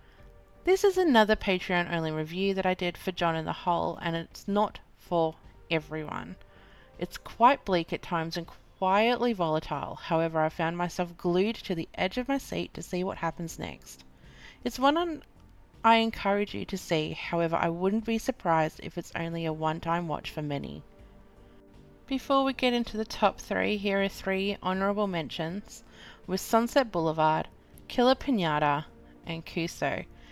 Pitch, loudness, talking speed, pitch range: 180 Hz, -29 LUFS, 160 wpm, 165-215 Hz